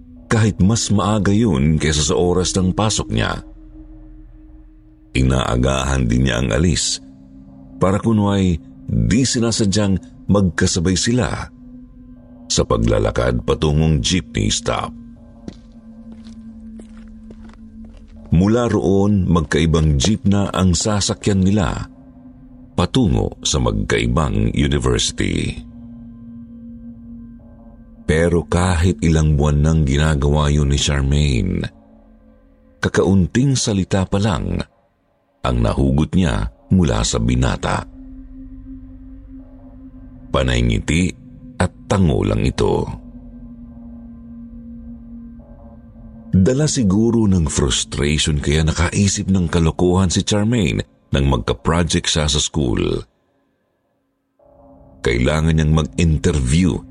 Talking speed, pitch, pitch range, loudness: 85 wpm, 95 Hz, 75-115 Hz, -17 LUFS